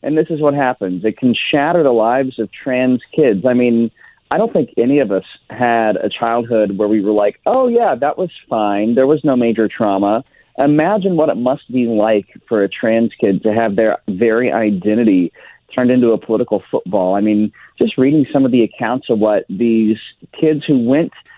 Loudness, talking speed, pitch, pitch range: -15 LUFS, 200 wpm, 120 Hz, 110-140 Hz